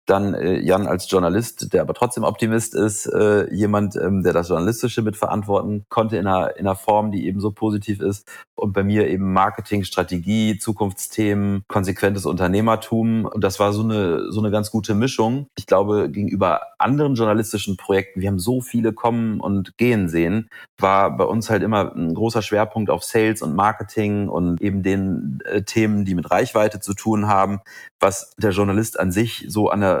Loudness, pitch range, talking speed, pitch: -20 LUFS, 95-110 Hz, 170 wpm, 105 Hz